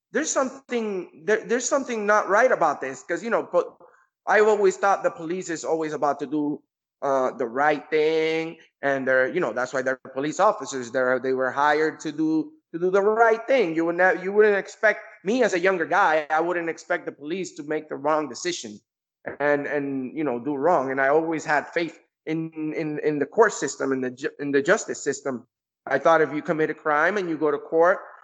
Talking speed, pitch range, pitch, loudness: 220 wpm, 145-190 Hz, 160 Hz, -23 LUFS